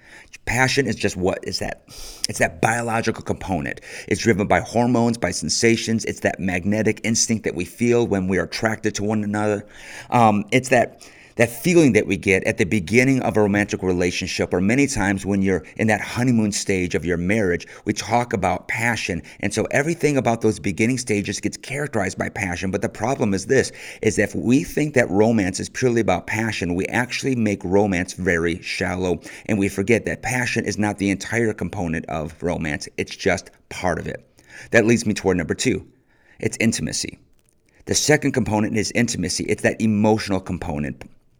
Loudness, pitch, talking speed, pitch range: -21 LUFS, 105 Hz, 185 wpm, 95-115 Hz